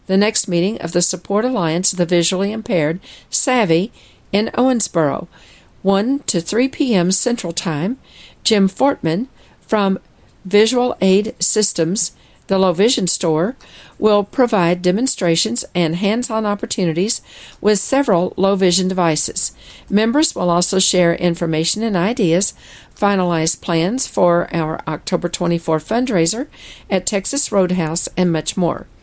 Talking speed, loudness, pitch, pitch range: 125 wpm, -16 LUFS, 190 Hz, 170-220 Hz